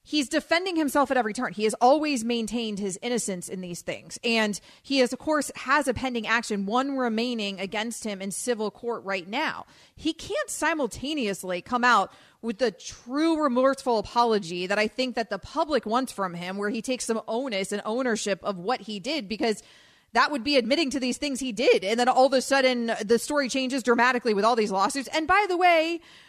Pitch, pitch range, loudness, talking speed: 245 Hz, 215-275 Hz, -26 LUFS, 210 wpm